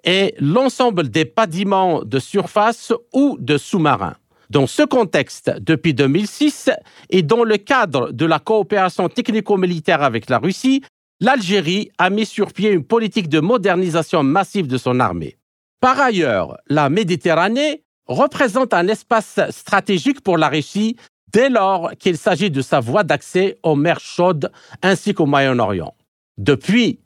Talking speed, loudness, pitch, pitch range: 140 wpm, -17 LUFS, 195 Hz, 160-225 Hz